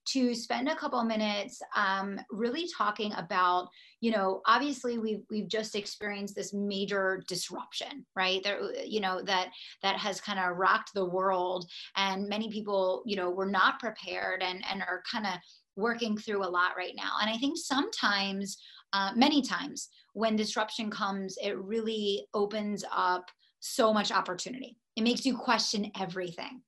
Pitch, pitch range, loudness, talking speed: 205 Hz, 190-225 Hz, -31 LUFS, 165 wpm